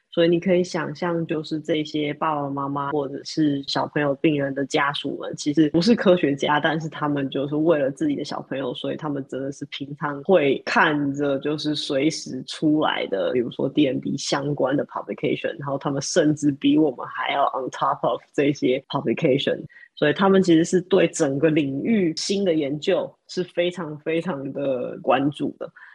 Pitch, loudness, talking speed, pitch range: 150 Hz, -23 LUFS, 330 characters per minute, 140-170 Hz